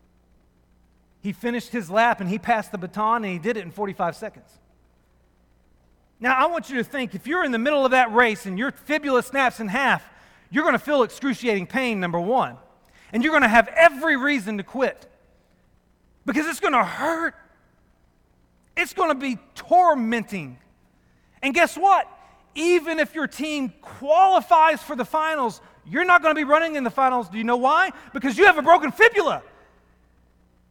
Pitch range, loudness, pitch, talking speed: 195-305 Hz, -21 LUFS, 245 Hz, 170 wpm